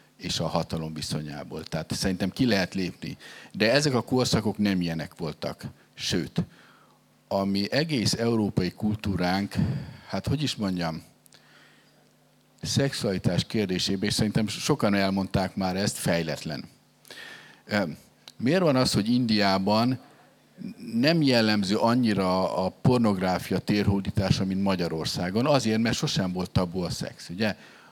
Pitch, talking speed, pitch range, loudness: 100 Hz, 120 wpm, 95-115 Hz, -26 LUFS